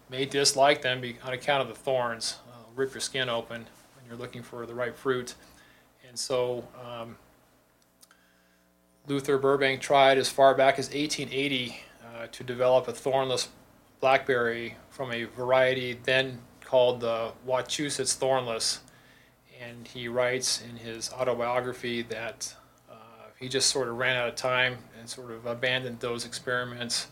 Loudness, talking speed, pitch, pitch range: -27 LUFS, 150 wpm, 125 Hz, 115-130 Hz